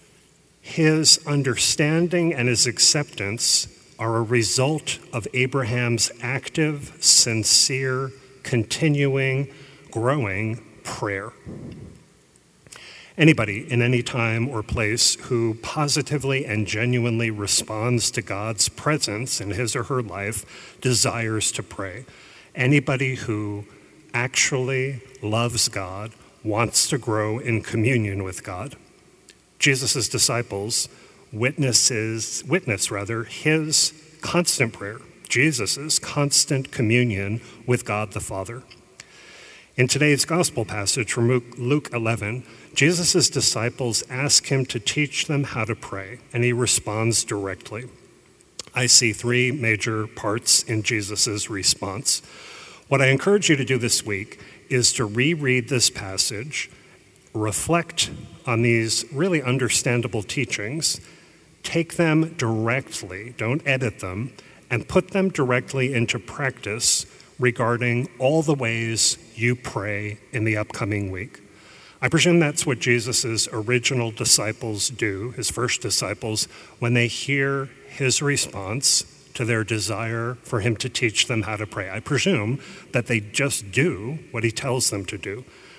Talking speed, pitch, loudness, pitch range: 120 wpm, 120 Hz, -21 LUFS, 110-135 Hz